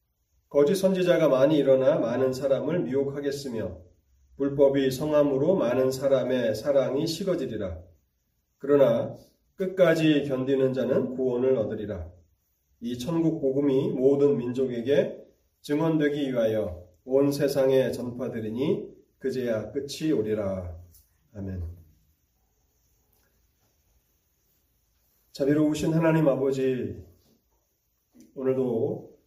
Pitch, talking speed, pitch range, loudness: 130 Hz, 230 characters per minute, 95-140 Hz, -25 LUFS